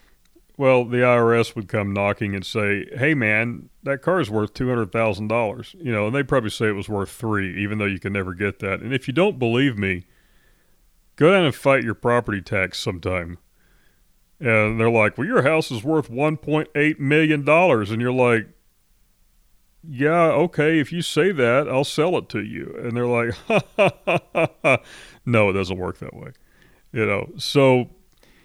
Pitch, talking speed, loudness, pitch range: 115 Hz, 190 wpm, -21 LUFS, 105-140 Hz